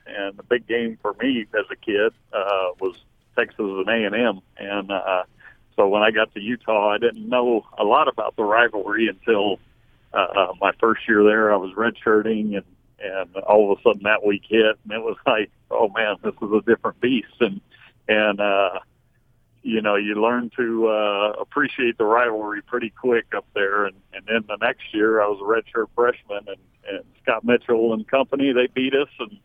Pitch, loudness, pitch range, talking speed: 110 Hz, -21 LUFS, 105-120 Hz, 195 wpm